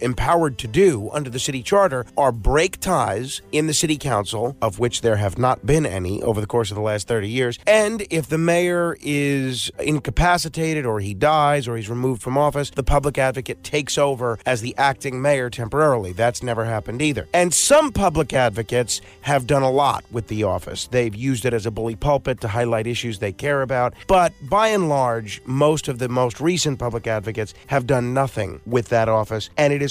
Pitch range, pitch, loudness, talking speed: 115-145 Hz, 130 Hz, -20 LUFS, 205 wpm